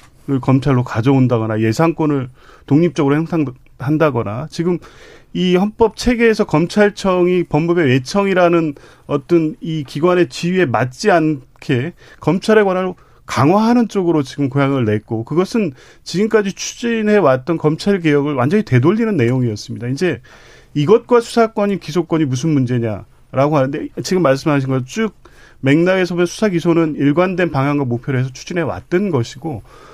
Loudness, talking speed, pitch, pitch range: -16 LUFS, 345 characters per minute, 155 Hz, 130-180 Hz